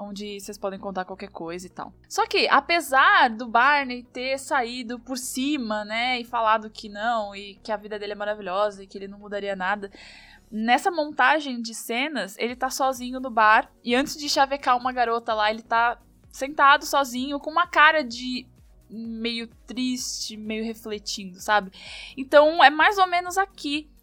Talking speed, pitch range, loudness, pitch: 175 wpm, 210-275 Hz, -23 LUFS, 240 Hz